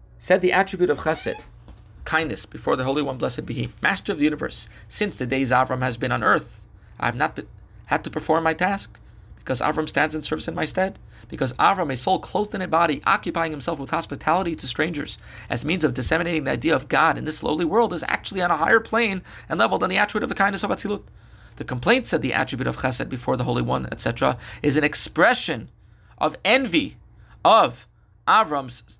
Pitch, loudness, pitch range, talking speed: 150 Hz, -22 LUFS, 125-170 Hz, 215 wpm